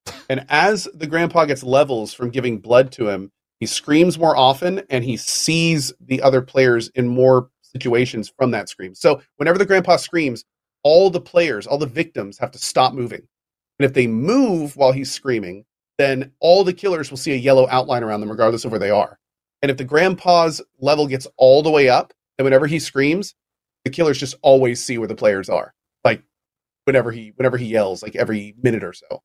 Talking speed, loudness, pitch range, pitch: 205 wpm, -18 LUFS, 120-155 Hz, 130 Hz